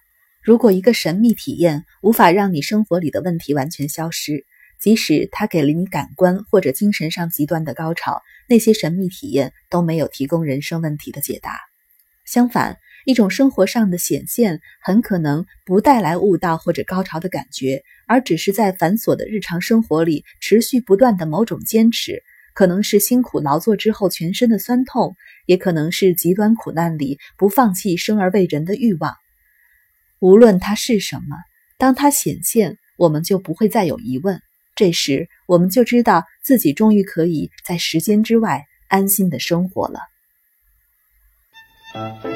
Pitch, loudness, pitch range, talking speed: 190 Hz, -17 LUFS, 165-225 Hz, 255 characters per minute